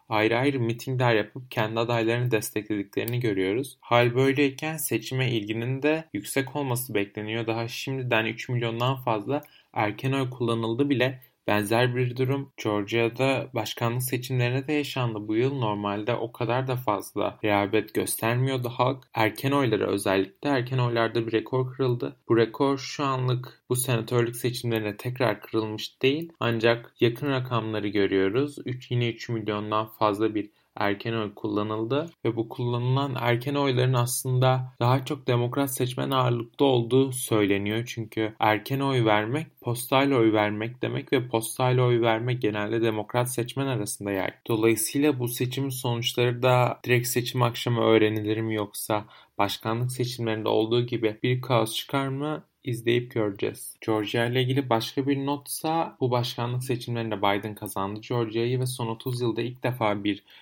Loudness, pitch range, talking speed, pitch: -26 LUFS, 110-130 Hz, 145 wpm, 120 Hz